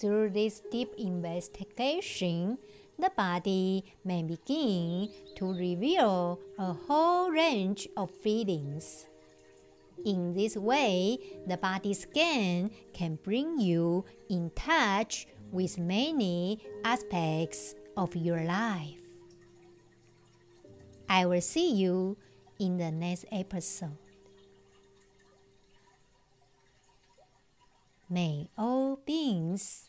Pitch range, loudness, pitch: 170-210 Hz, -31 LUFS, 185 Hz